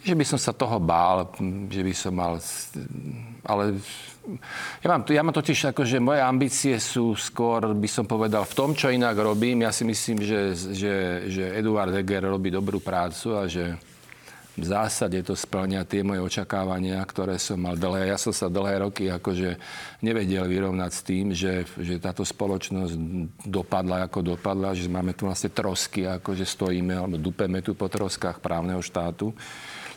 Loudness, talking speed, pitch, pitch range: -26 LUFS, 170 wpm, 95 Hz, 90-110 Hz